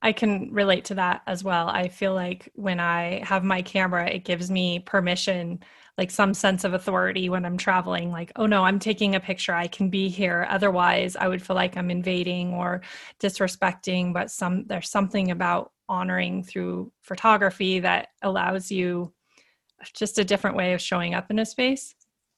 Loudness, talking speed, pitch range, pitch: -25 LUFS, 180 wpm, 180-195 Hz, 185 Hz